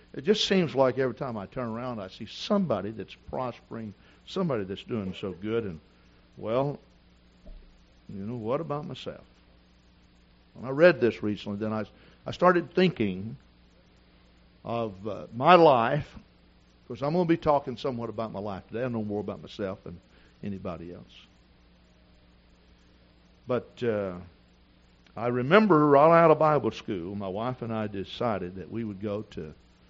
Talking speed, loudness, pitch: 155 wpm, -27 LUFS, 100 Hz